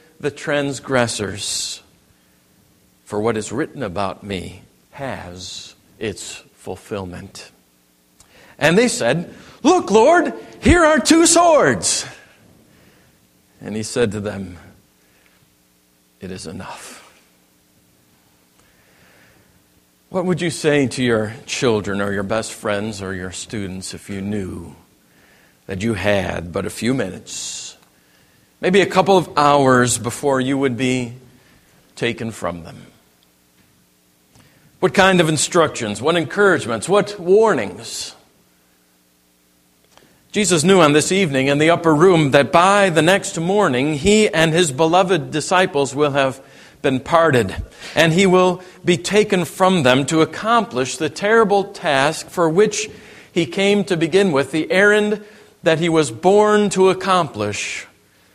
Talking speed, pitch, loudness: 125 wpm, 140 Hz, -17 LUFS